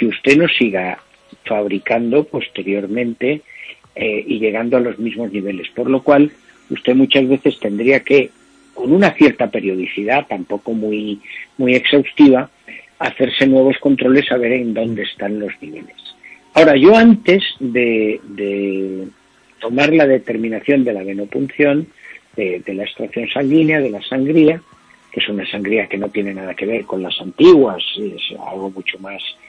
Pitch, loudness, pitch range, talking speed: 120 Hz, -15 LUFS, 100-135 Hz, 155 wpm